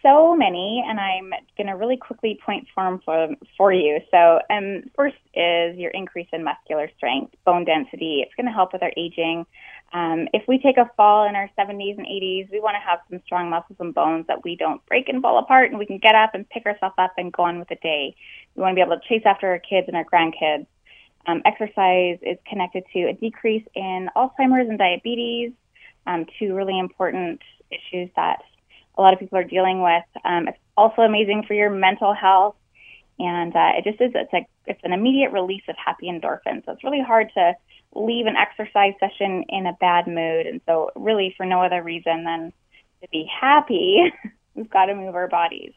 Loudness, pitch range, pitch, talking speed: -20 LUFS, 175-220 Hz, 190 Hz, 210 wpm